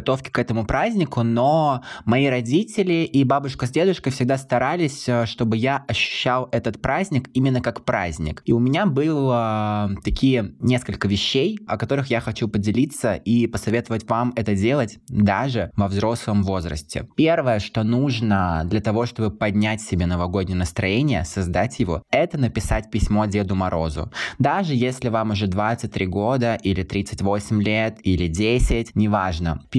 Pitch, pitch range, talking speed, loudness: 115 Hz, 100-130 Hz, 145 wpm, -21 LUFS